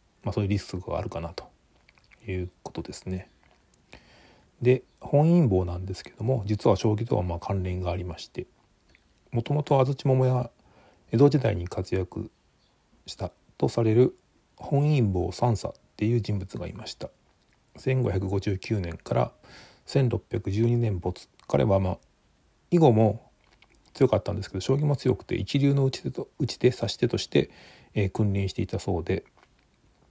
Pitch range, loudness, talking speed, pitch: 95-125 Hz, -27 LUFS, 275 characters per minute, 110 Hz